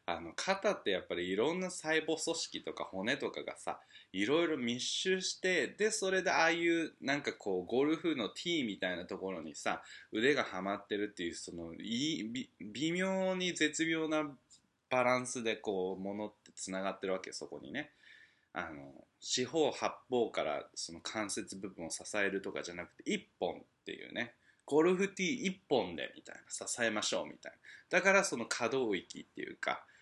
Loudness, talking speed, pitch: -36 LUFS, 345 characters per minute, 155 Hz